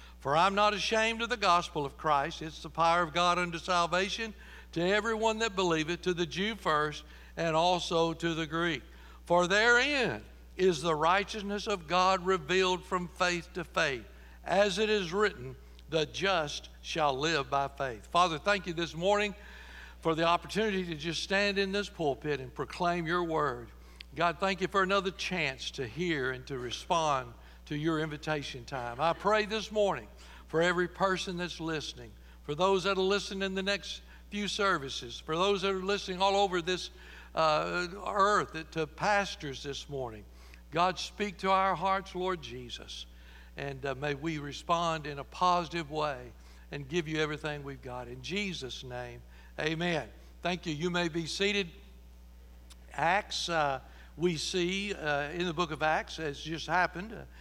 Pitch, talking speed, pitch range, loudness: 170 Hz, 170 wpm, 140-190 Hz, -31 LUFS